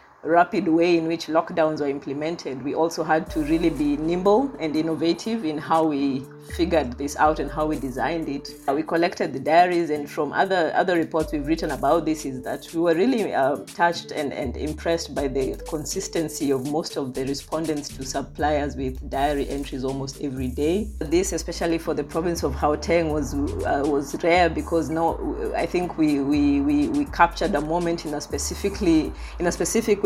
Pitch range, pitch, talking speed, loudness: 145-170 Hz, 160 Hz, 190 wpm, -24 LUFS